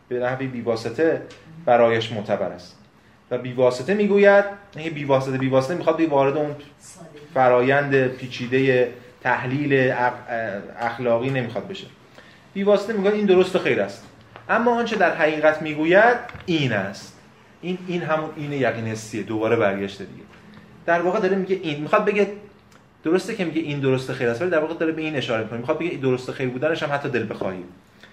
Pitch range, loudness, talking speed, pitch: 125-170 Hz, -22 LUFS, 170 wpm, 140 Hz